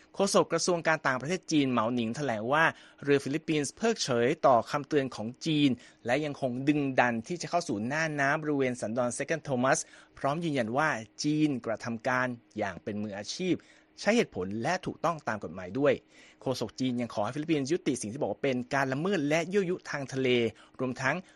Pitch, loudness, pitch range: 135 Hz, -30 LUFS, 125-155 Hz